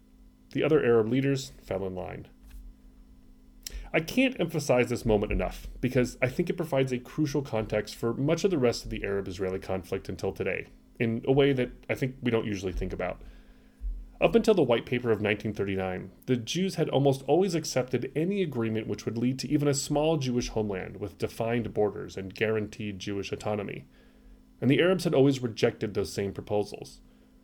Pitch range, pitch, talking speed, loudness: 100-135 Hz, 115 Hz, 185 wpm, -29 LUFS